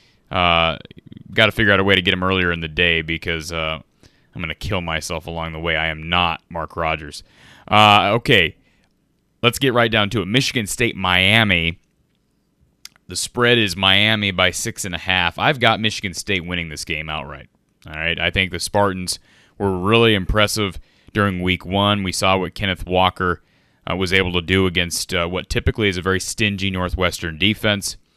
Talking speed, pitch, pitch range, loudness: 185 wpm, 95 Hz, 85-105 Hz, -18 LUFS